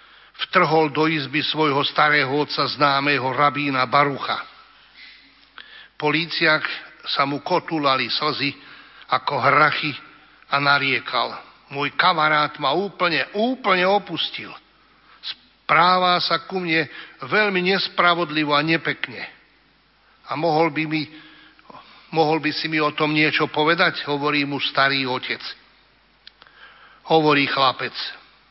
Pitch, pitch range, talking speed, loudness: 155 Hz, 145-165 Hz, 105 wpm, -20 LUFS